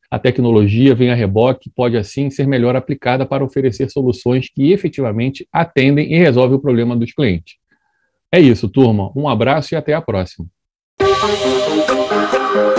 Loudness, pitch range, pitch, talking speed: -15 LUFS, 115-140 Hz, 130 Hz, 145 wpm